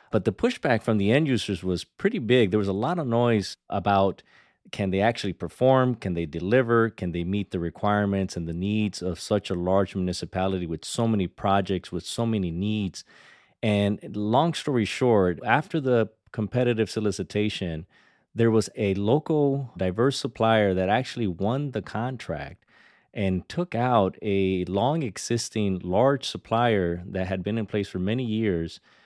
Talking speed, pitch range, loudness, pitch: 165 wpm, 95-120 Hz, -25 LUFS, 105 Hz